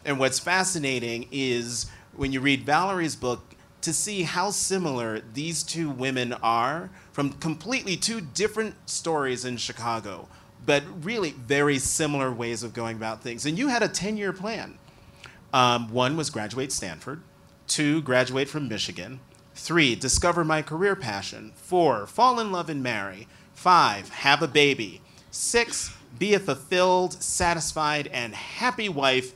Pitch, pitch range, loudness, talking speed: 145 Hz, 125-175 Hz, -25 LUFS, 145 wpm